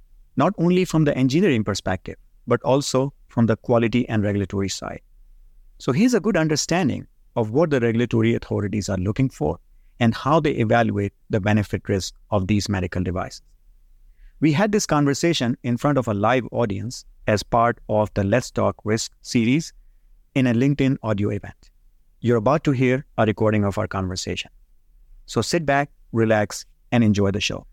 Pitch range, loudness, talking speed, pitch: 100-135 Hz, -22 LUFS, 170 wpm, 115 Hz